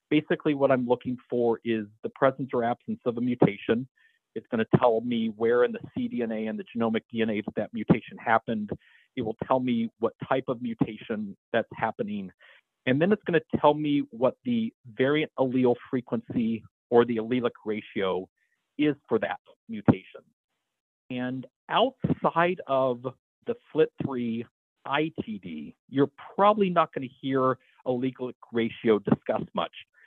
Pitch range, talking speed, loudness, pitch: 120-160 Hz, 150 wpm, -27 LUFS, 130 Hz